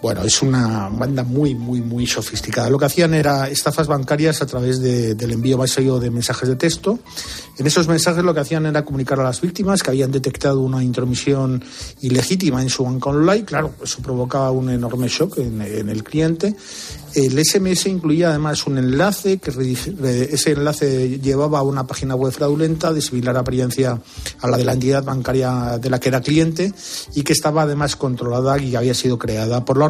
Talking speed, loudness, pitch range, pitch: 190 wpm, -18 LUFS, 125-150 Hz, 135 Hz